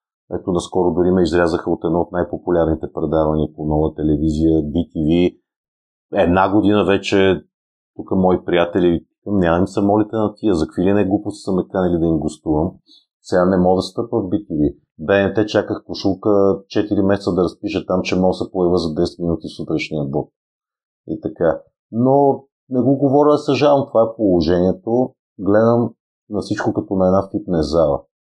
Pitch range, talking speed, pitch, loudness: 85-105 Hz, 165 wpm, 95 Hz, -18 LUFS